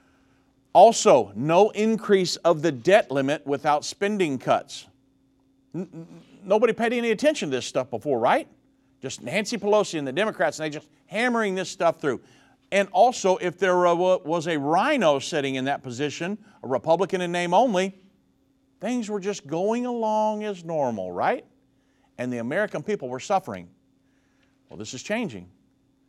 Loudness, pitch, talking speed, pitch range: -23 LUFS, 175 Hz, 155 wpm, 135-210 Hz